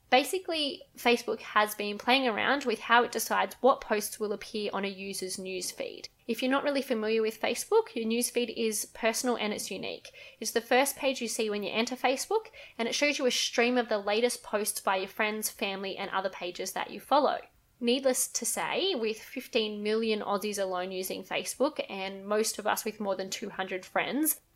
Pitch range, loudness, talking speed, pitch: 205-255 Hz, -30 LUFS, 200 wpm, 225 Hz